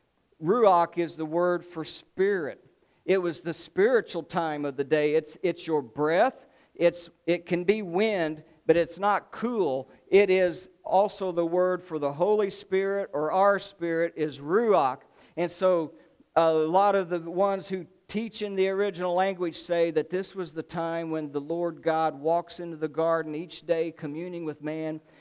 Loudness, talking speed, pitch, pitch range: -27 LUFS, 175 wpm, 170 Hz, 160-190 Hz